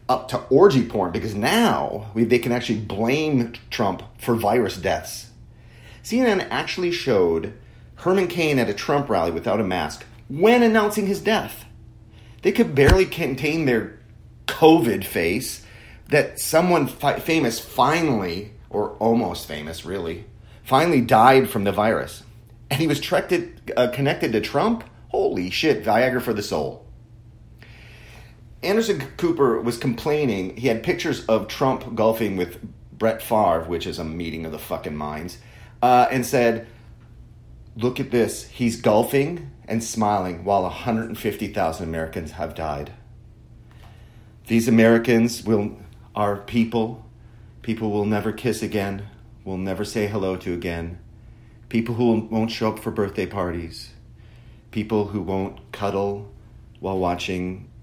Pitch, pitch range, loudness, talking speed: 115 Hz, 105-125 Hz, -22 LUFS, 135 wpm